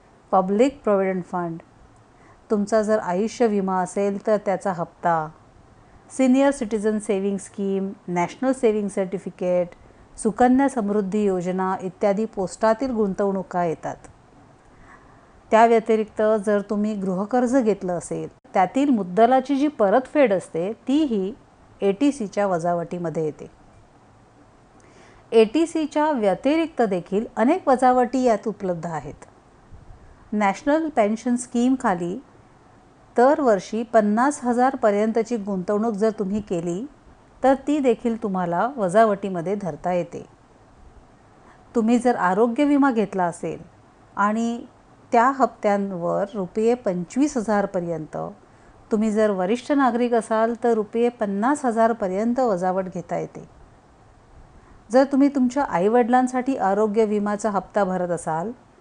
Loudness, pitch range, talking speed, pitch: -22 LUFS, 190-240 Hz, 105 wpm, 215 Hz